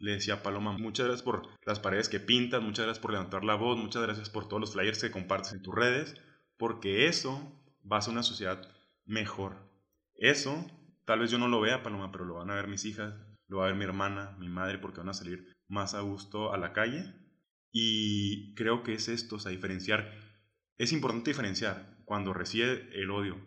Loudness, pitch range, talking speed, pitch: -33 LUFS, 100-115 Hz, 215 wpm, 105 Hz